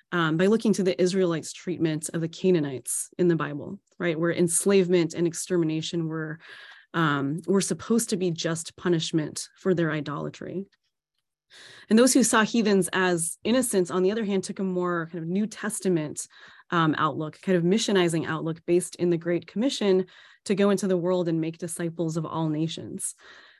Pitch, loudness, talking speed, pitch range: 175 Hz, -25 LUFS, 175 wpm, 165-190 Hz